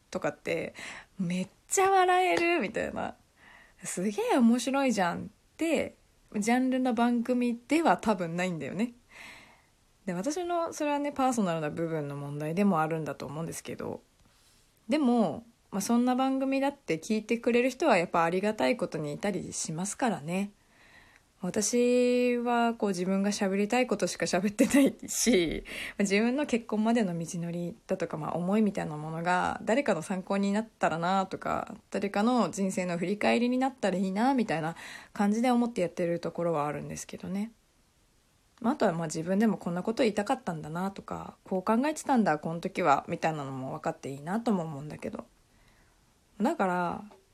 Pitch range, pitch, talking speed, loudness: 175-245 Hz, 205 Hz, 360 characters per minute, -29 LUFS